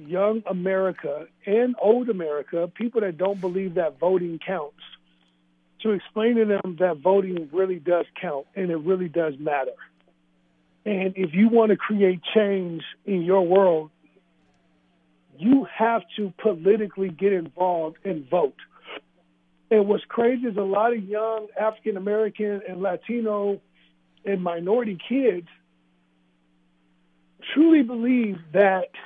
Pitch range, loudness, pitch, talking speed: 155-210 Hz, -23 LUFS, 190 Hz, 130 wpm